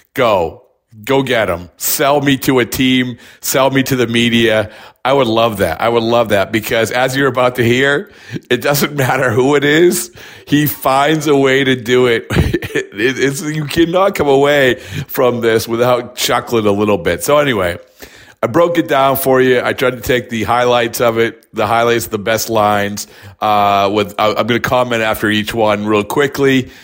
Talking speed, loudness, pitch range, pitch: 190 wpm, -13 LUFS, 110-135 Hz, 125 Hz